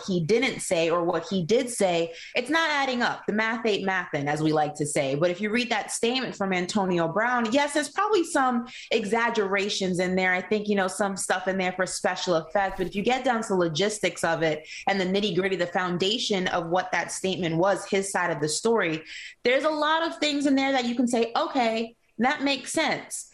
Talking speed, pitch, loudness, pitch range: 225 wpm, 200 Hz, -25 LUFS, 185-245 Hz